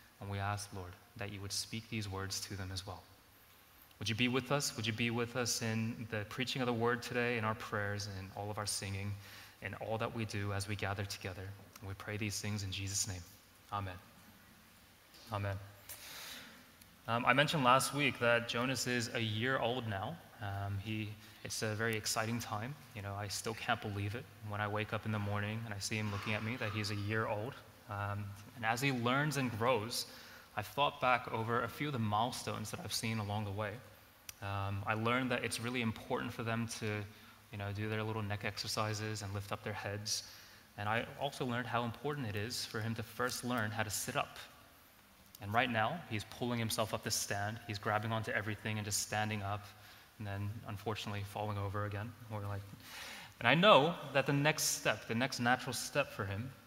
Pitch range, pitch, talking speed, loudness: 100-120 Hz, 110 Hz, 215 wpm, -37 LUFS